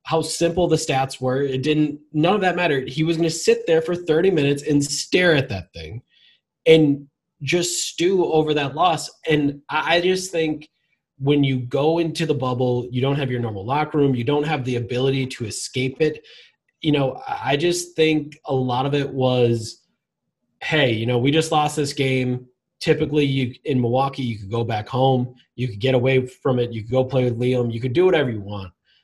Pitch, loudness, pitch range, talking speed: 140 Hz, -21 LUFS, 125-155 Hz, 210 wpm